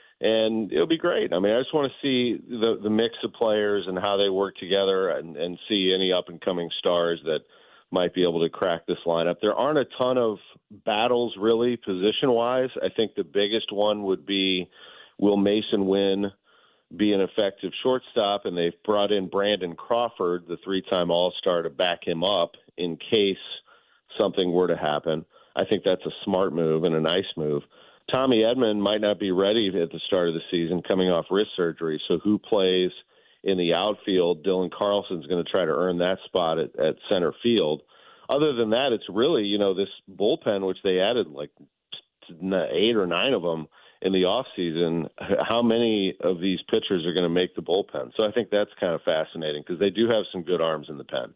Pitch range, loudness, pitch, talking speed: 85-105 Hz, -24 LUFS, 95 Hz, 205 wpm